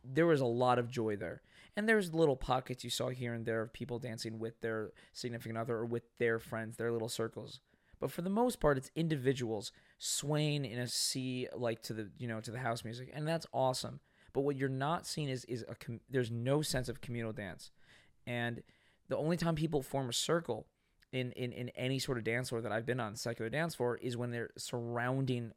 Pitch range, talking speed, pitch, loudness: 115-135 Hz, 220 wpm, 125 Hz, -37 LUFS